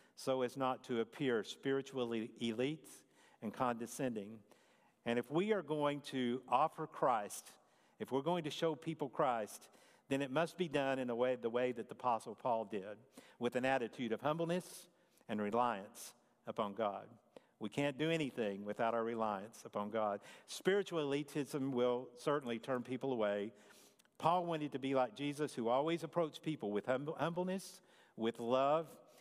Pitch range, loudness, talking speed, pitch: 120-155 Hz, -39 LUFS, 160 wpm, 130 Hz